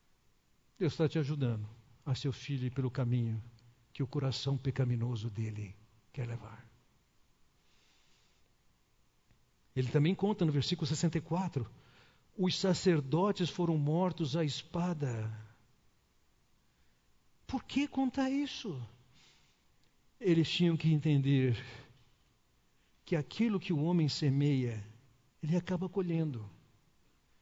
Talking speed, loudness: 100 wpm, -34 LUFS